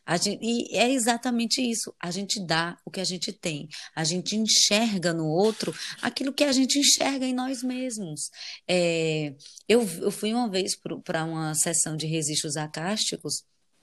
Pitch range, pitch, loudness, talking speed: 165-235 Hz, 195 Hz, -25 LUFS, 170 wpm